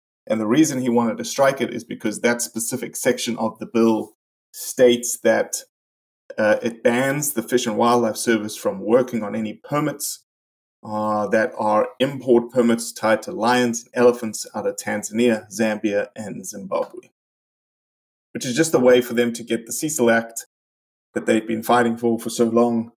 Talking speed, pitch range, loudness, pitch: 175 wpm, 110-120 Hz, -21 LUFS, 115 Hz